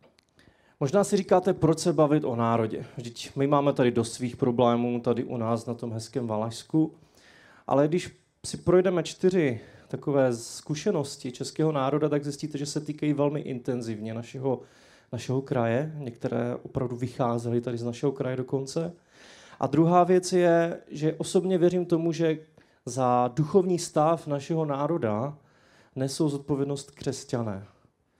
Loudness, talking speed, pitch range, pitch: -27 LUFS, 140 wpm, 125-160 Hz, 140 Hz